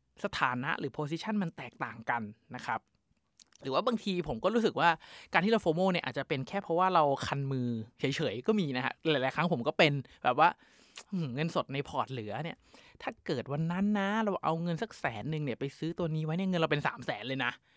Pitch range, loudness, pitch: 135-180 Hz, -32 LUFS, 155 Hz